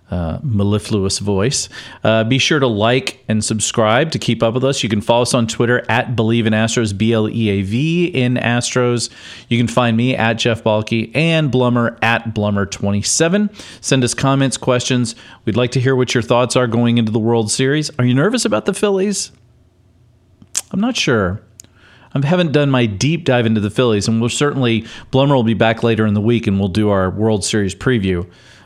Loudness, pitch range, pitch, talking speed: -16 LUFS, 110-130 Hz, 120 Hz, 195 wpm